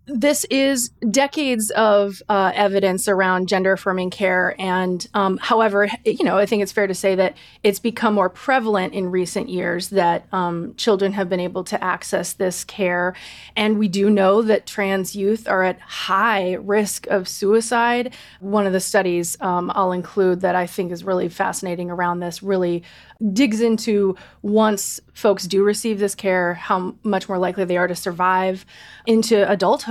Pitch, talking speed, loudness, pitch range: 195 Hz, 175 wpm, -20 LUFS, 185-215 Hz